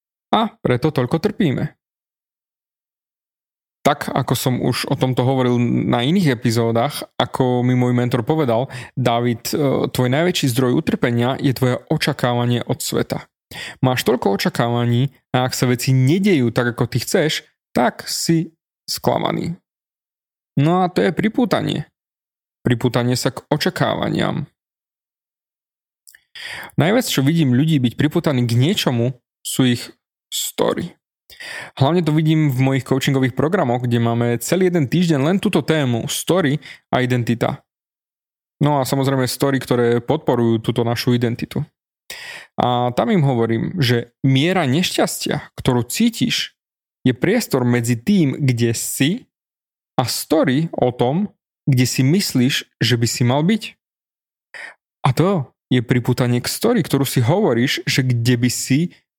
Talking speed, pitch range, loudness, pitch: 135 wpm, 125-160 Hz, -18 LUFS, 130 Hz